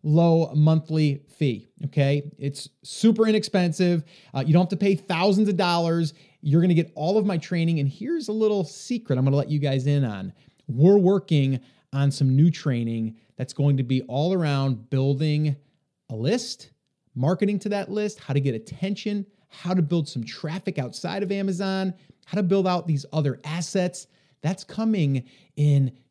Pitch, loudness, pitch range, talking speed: 160 Hz, -24 LUFS, 140-190 Hz, 180 wpm